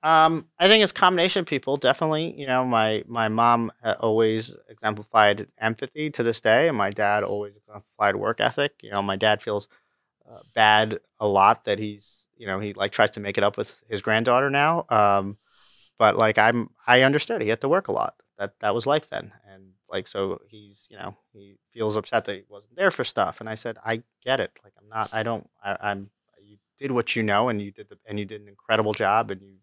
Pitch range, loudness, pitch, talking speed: 105-125 Hz, -23 LUFS, 110 Hz, 225 wpm